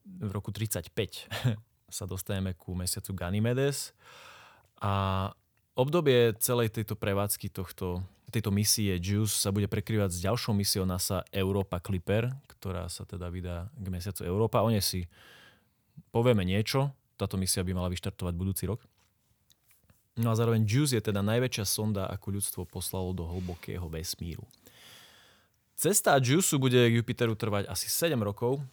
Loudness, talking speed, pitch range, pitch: -30 LUFS, 140 wpm, 95-115 Hz, 100 Hz